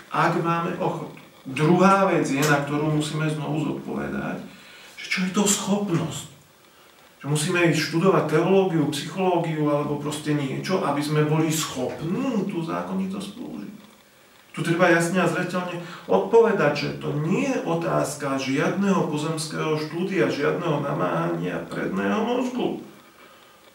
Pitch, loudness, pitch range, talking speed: 165 Hz, -23 LUFS, 150-185 Hz, 125 wpm